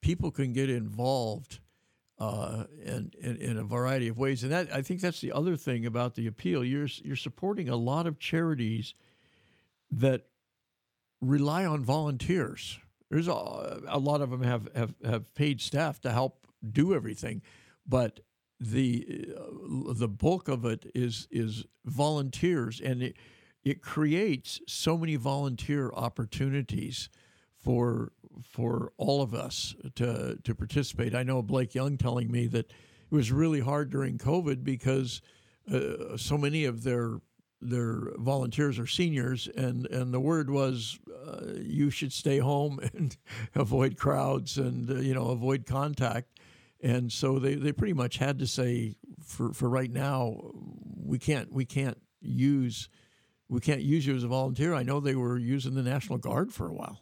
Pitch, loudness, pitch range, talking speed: 130 Hz, -31 LUFS, 120-145 Hz, 160 wpm